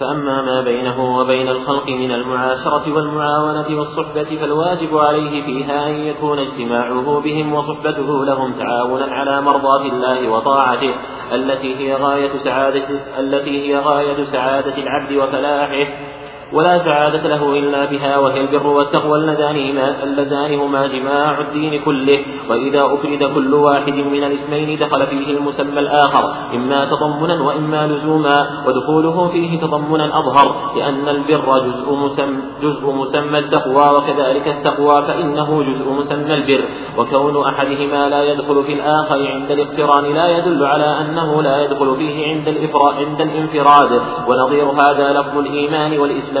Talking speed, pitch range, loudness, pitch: 130 wpm, 140-150 Hz, -15 LUFS, 145 Hz